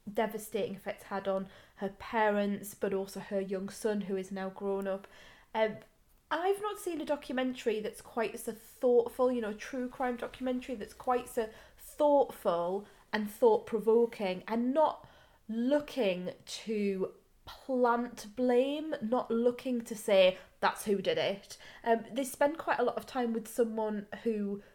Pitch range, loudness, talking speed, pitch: 205-250 Hz, -33 LUFS, 155 wpm, 225 Hz